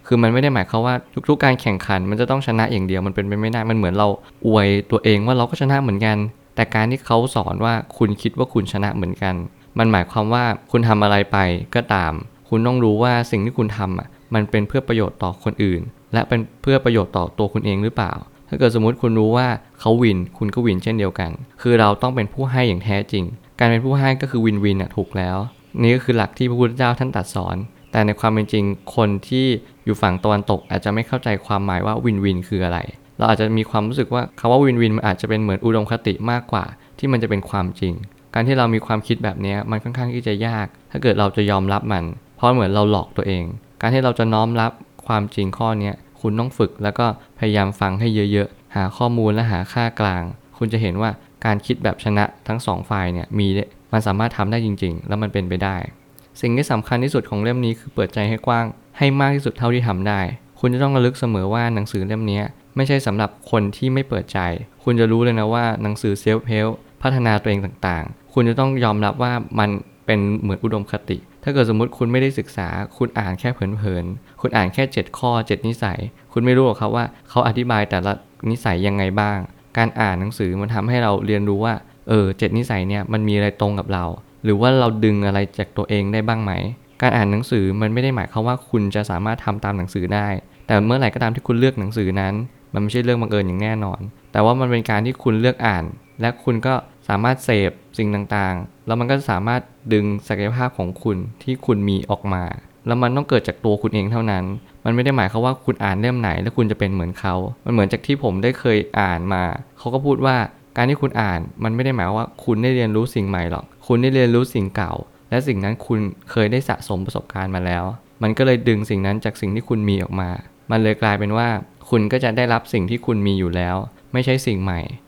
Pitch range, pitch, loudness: 100-120 Hz, 110 Hz, -20 LUFS